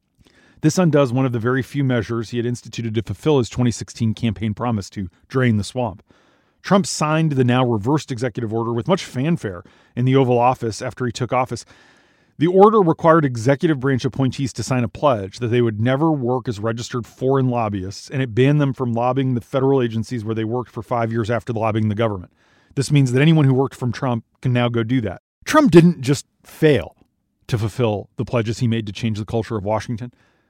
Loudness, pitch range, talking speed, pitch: -19 LUFS, 115-135 Hz, 205 wpm, 125 Hz